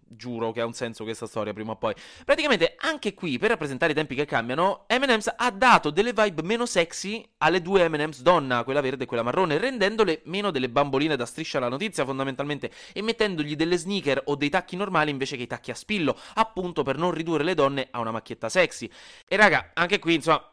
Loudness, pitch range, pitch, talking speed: -25 LUFS, 135-205 Hz, 160 Hz, 215 wpm